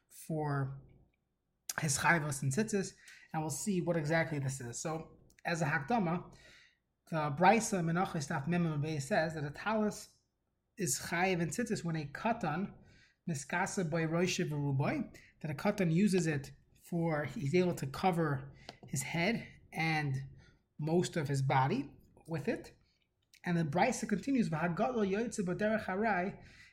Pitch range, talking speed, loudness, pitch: 150-190 Hz, 130 wpm, -35 LUFS, 165 Hz